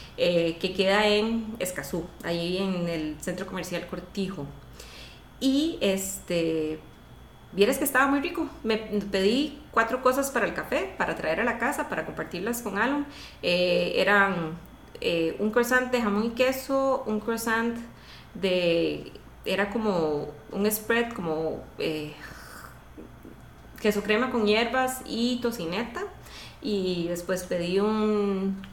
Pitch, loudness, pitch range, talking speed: 200 Hz, -27 LUFS, 175-235 Hz, 130 wpm